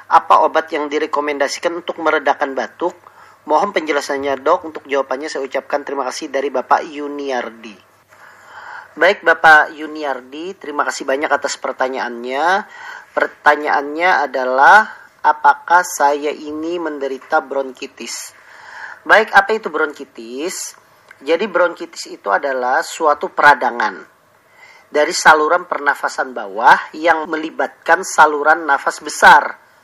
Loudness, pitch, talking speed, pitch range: -15 LUFS, 150 Hz, 105 wpm, 140-170 Hz